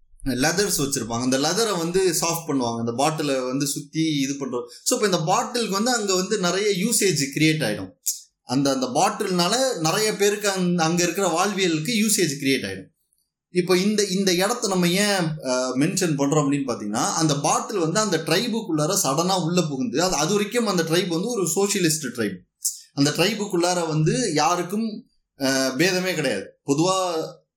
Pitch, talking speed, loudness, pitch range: 170 Hz, 150 wpm, -22 LUFS, 140-195 Hz